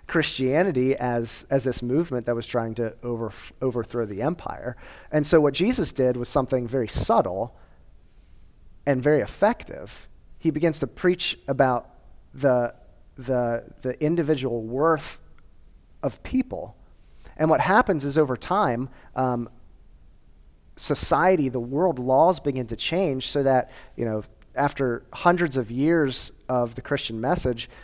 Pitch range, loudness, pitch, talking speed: 115-145 Hz, -24 LUFS, 130 Hz, 135 wpm